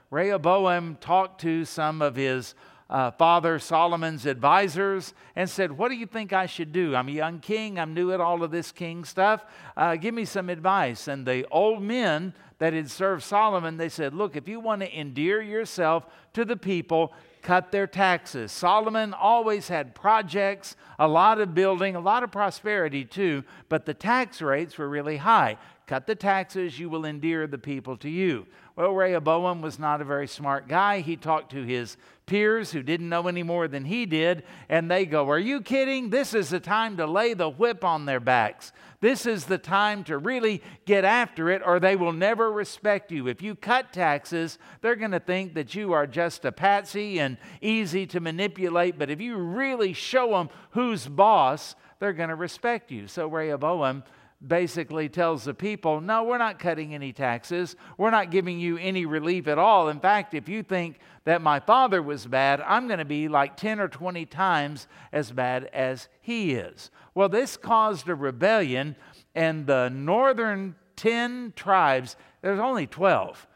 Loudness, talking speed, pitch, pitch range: -25 LUFS, 190 wpm, 175 Hz, 155-205 Hz